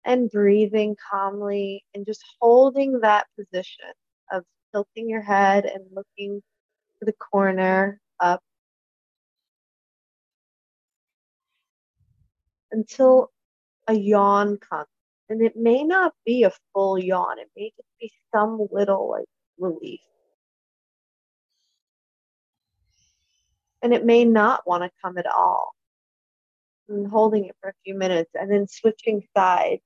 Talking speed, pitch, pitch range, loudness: 115 wpm, 205 Hz, 195-225 Hz, -21 LUFS